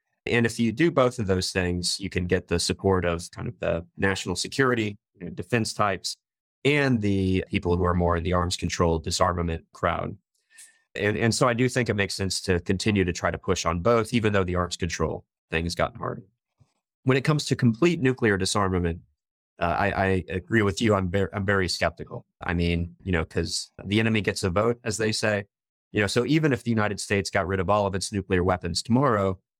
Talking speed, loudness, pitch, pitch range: 220 wpm, -25 LUFS, 100 Hz, 90-115 Hz